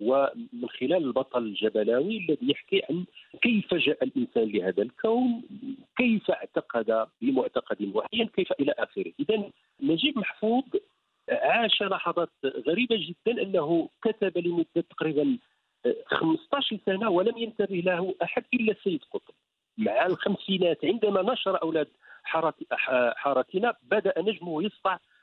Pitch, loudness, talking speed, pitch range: 215 Hz, -27 LUFS, 115 wpm, 170-255 Hz